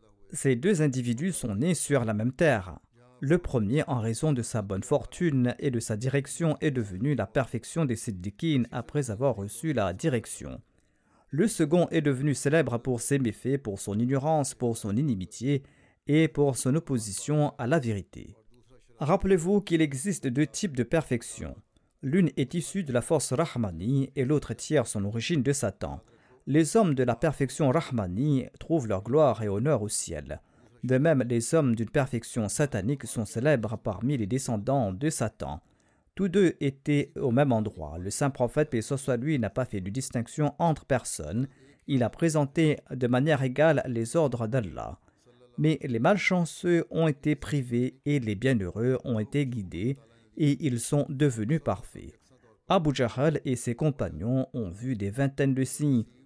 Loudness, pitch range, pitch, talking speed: -28 LUFS, 115-150 Hz, 130 Hz, 165 wpm